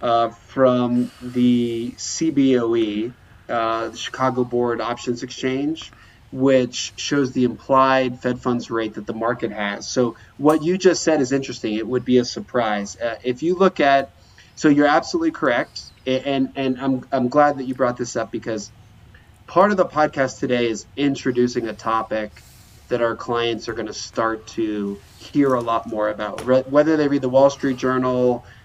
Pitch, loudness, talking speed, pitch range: 125 Hz, -21 LUFS, 175 wpm, 110-135 Hz